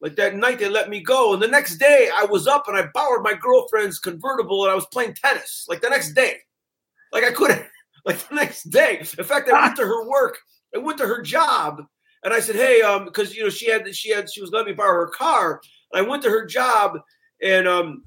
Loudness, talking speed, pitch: -19 LUFS, 250 wpm, 275 Hz